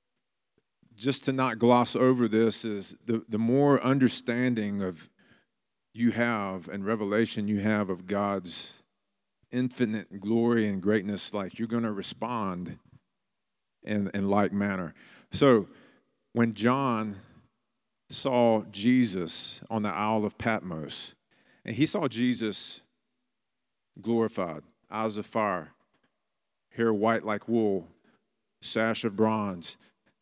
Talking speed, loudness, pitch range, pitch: 115 wpm, -28 LUFS, 100-120 Hz, 110 Hz